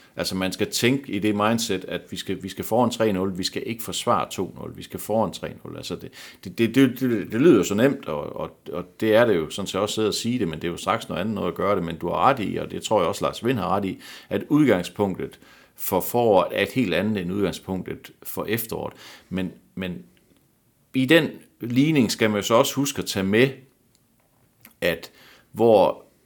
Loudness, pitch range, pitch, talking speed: -23 LUFS, 95-125 Hz, 105 Hz, 230 wpm